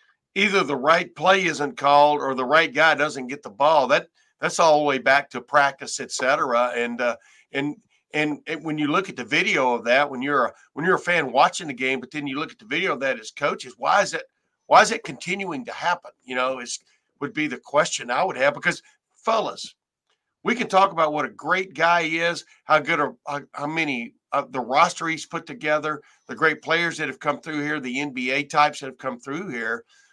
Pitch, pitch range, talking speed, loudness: 150 Hz, 140-170 Hz, 235 wpm, -22 LUFS